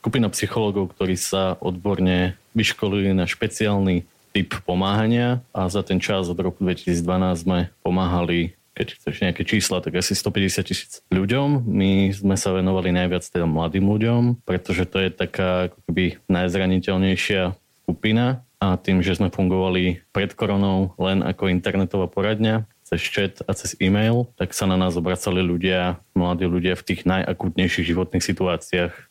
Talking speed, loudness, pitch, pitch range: 150 wpm, -22 LUFS, 95 Hz, 90-100 Hz